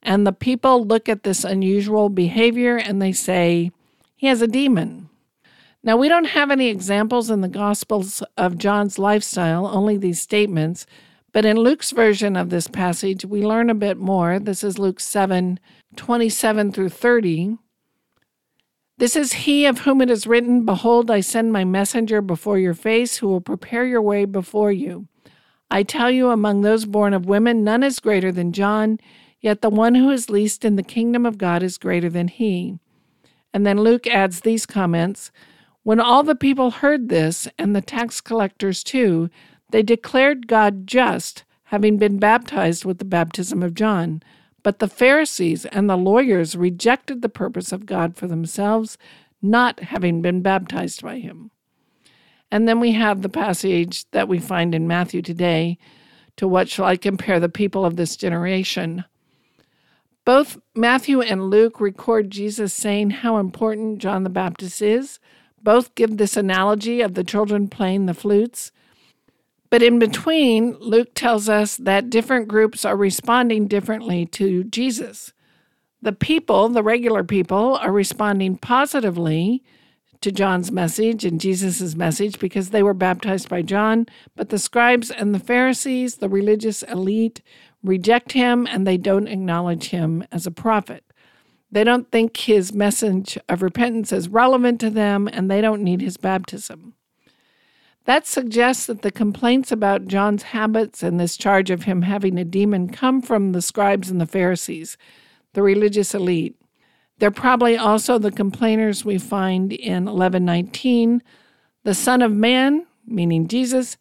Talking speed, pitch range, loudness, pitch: 160 wpm, 190-230 Hz, -19 LUFS, 205 Hz